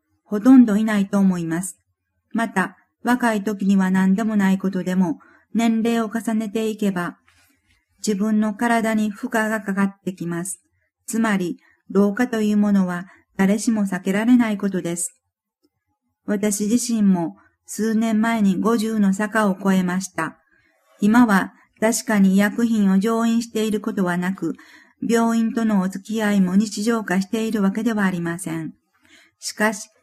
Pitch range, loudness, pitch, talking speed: 190-225 Hz, -20 LUFS, 210 Hz, 280 characters per minute